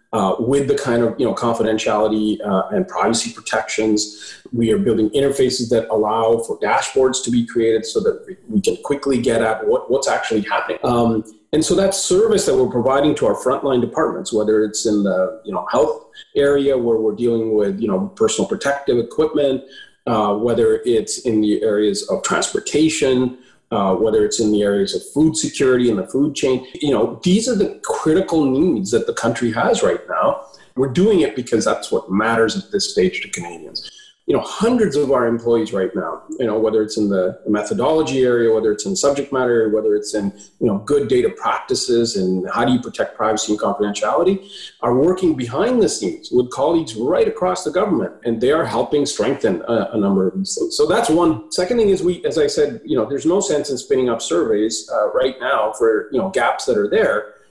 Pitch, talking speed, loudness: 130 Hz, 205 wpm, -18 LUFS